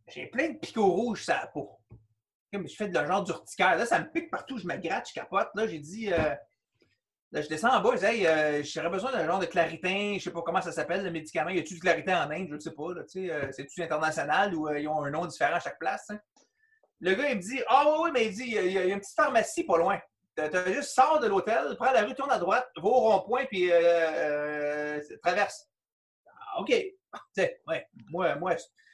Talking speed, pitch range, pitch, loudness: 255 wpm, 155-225 Hz, 180 Hz, -28 LUFS